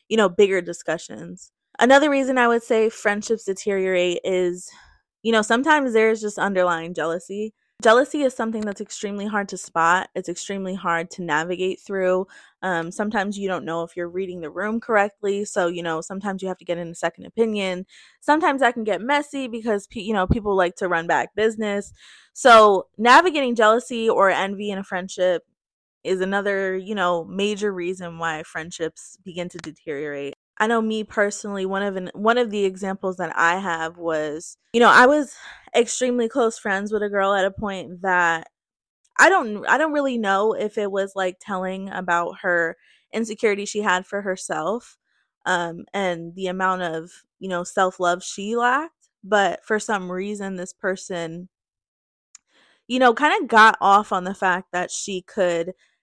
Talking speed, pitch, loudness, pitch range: 175 wpm, 195 Hz, -21 LUFS, 180-220 Hz